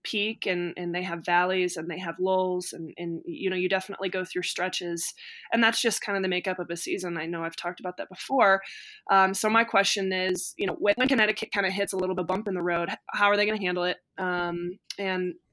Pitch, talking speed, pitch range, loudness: 185 Hz, 245 wpm, 175-200 Hz, -27 LUFS